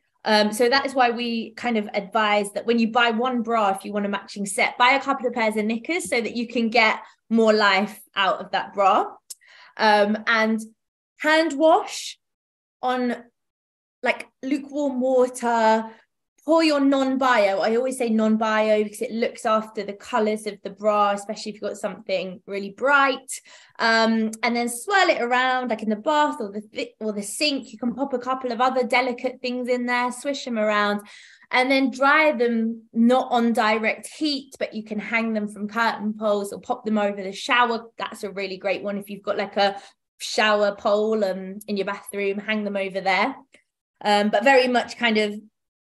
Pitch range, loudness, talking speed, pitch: 210-250 Hz, -22 LUFS, 195 wpm, 225 Hz